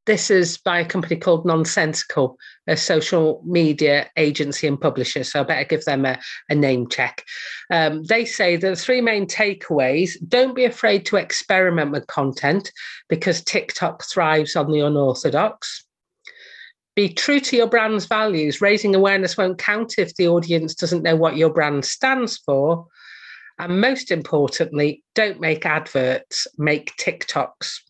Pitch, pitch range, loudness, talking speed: 170 Hz, 150-200 Hz, -19 LUFS, 150 wpm